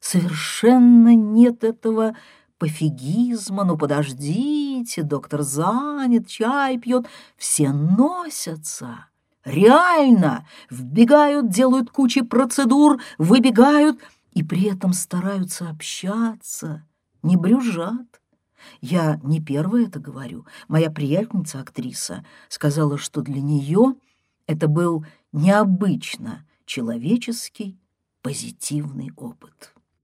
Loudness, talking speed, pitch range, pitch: -19 LUFS, 85 wpm, 155-240 Hz, 195 Hz